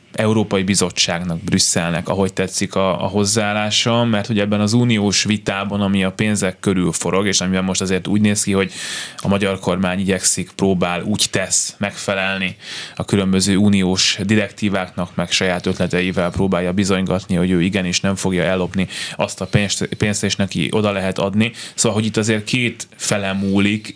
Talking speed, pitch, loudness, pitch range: 160 wpm, 100 Hz, -18 LUFS, 95-105 Hz